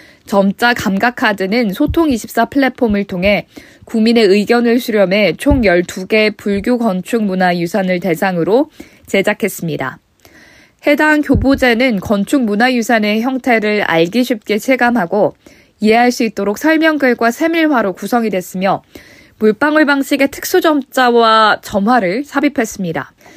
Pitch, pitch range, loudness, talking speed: 230 Hz, 200-260 Hz, -13 LUFS, 280 characters per minute